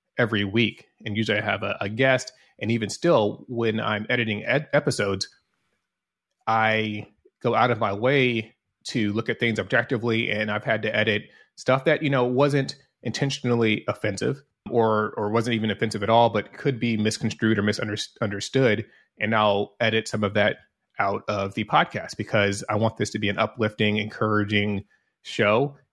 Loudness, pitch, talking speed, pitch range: -24 LUFS, 110 Hz, 170 wpm, 105-120 Hz